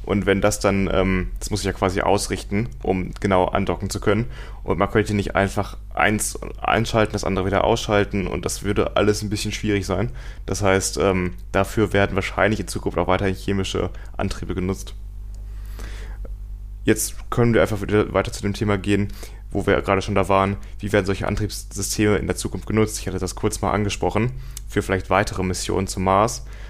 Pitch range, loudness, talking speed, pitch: 95-105 Hz, -22 LUFS, 185 wpm, 100 Hz